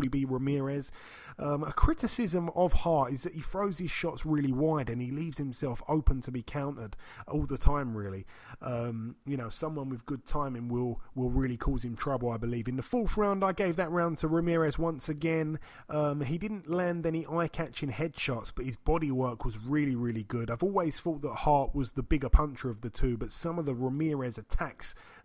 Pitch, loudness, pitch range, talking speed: 140 Hz, -32 LUFS, 125-165 Hz, 205 wpm